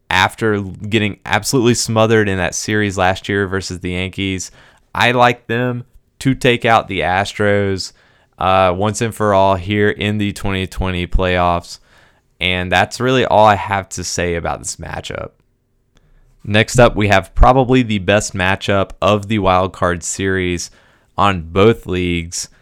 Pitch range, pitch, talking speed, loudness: 90-110 Hz, 100 Hz, 150 wpm, -16 LUFS